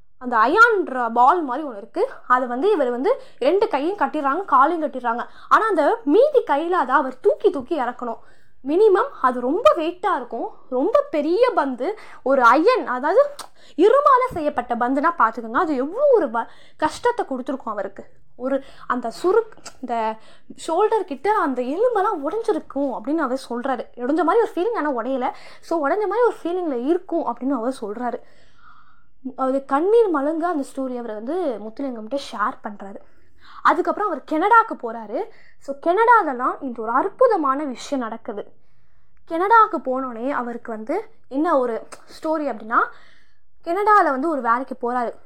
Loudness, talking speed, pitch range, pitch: -20 LUFS, 140 wpm, 250-375 Hz, 290 Hz